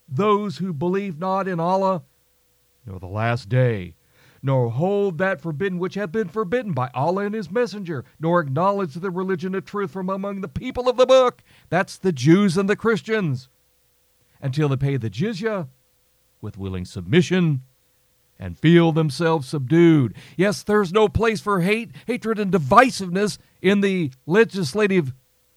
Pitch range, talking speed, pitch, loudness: 135-200 Hz, 155 wpm, 180 Hz, -21 LUFS